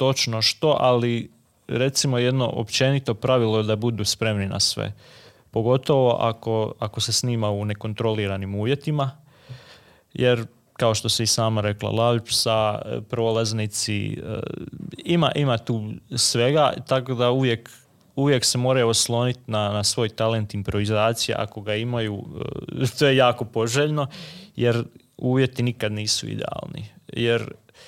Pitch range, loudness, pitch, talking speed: 110-130 Hz, -22 LUFS, 115 Hz, 125 wpm